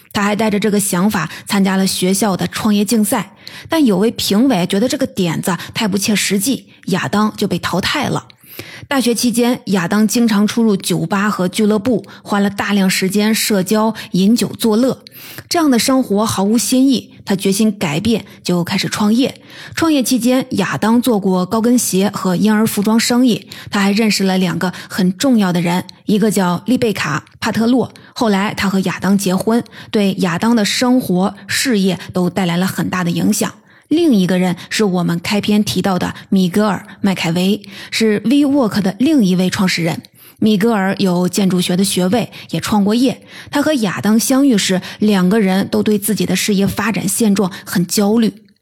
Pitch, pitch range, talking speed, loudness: 205 Hz, 190-225 Hz, 275 characters per minute, -15 LUFS